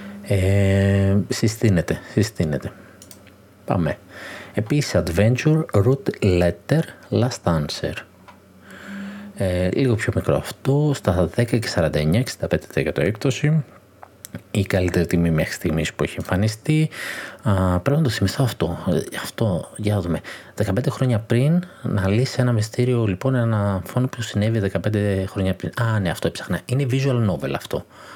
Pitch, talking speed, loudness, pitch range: 105 Hz, 135 wpm, -21 LUFS, 95-125 Hz